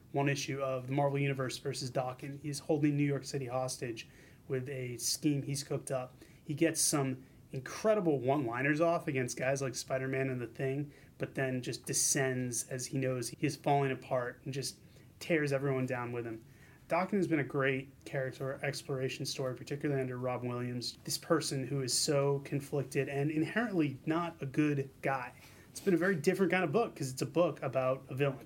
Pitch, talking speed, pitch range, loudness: 140 Hz, 190 wpm, 130-150 Hz, -34 LUFS